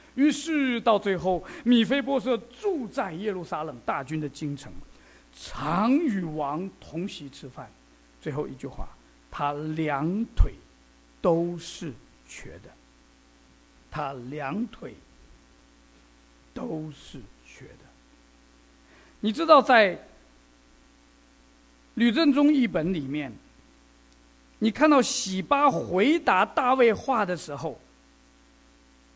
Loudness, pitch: -25 LUFS, 170 Hz